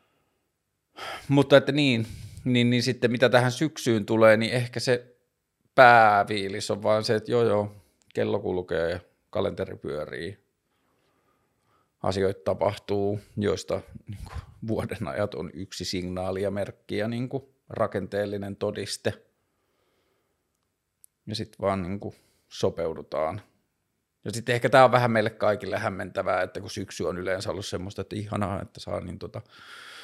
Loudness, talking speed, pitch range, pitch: -25 LUFS, 140 wpm, 100-120 Hz, 105 Hz